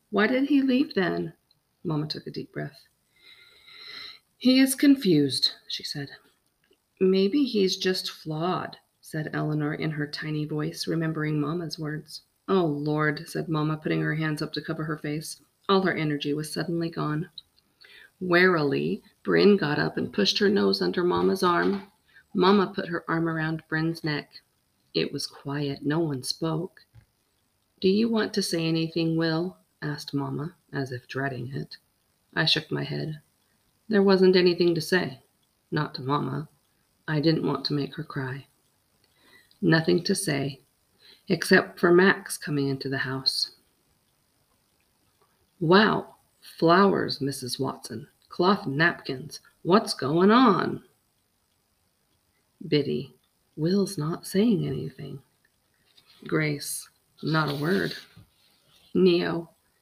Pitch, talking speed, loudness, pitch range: 160 Hz, 130 wpm, -25 LUFS, 150-190 Hz